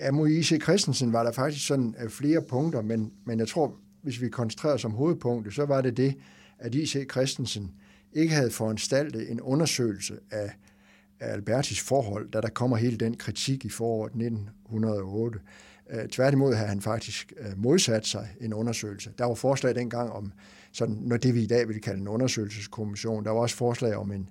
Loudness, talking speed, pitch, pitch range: -28 LUFS, 180 wpm, 115 Hz, 105-130 Hz